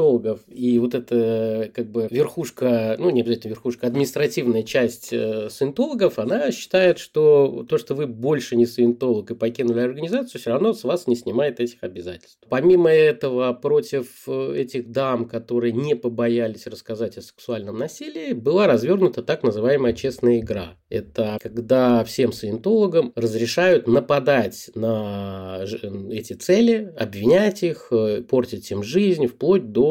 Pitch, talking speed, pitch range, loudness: 120 Hz, 135 wpm, 110-145 Hz, -21 LUFS